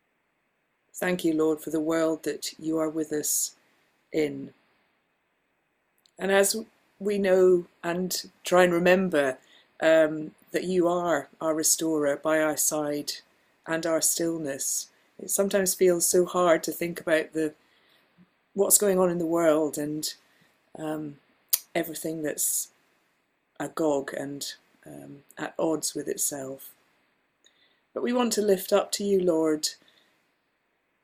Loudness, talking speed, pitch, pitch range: -26 LUFS, 130 wpm, 160 Hz, 155-180 Hz